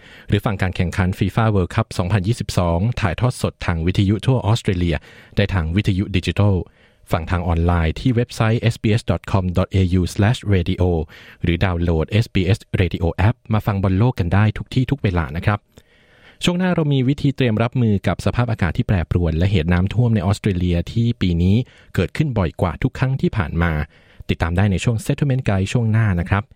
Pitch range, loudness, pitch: 90-115 Hz, -19 LUFS, 100 Hz